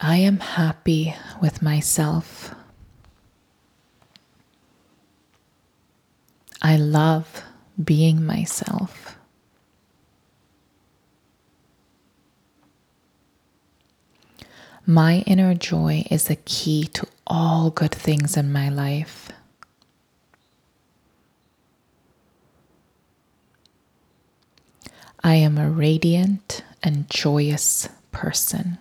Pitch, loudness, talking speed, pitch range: 155 Hz, -21 LUFS, 60 wpm, 150-170 Hz